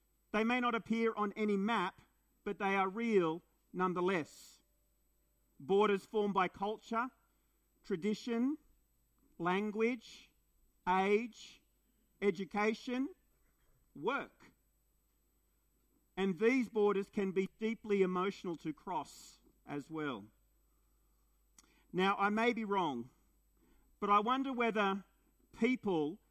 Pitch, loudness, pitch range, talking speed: 205 Hz, -36 LUFS, 190-230 Hz, 95 wpm